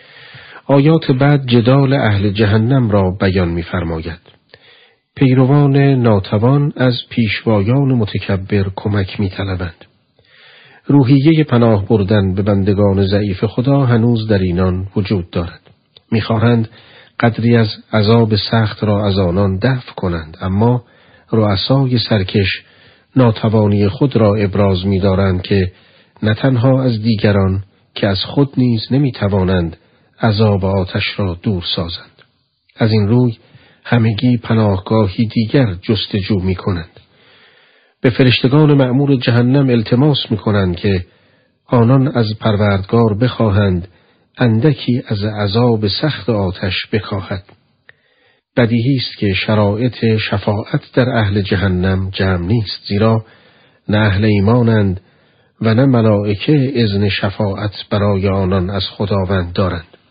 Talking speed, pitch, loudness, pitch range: 110 wpm, 110 Hz, -14 LUFS, 100-120 Hz